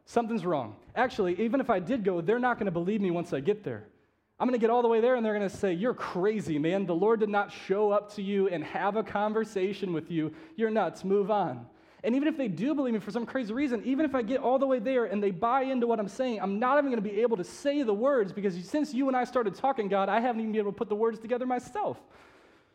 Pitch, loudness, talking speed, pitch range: 220 Hz, -29 LUFS, 285 wpm, 200-250 Hz